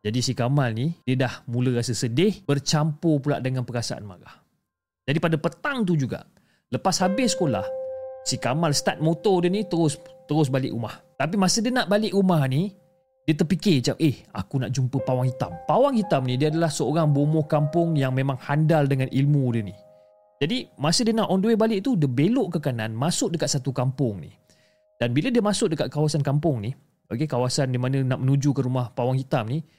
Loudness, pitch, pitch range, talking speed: -24 LUFS, 145 Hz, 130-170 Hz, 200 wpm